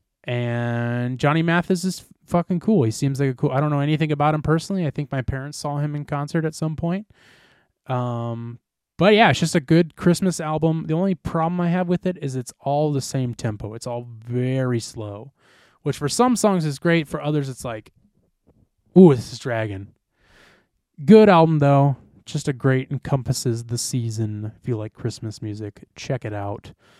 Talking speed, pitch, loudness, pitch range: 190 wpm, 140 Hz, -21 LUFS, 120-160 Hz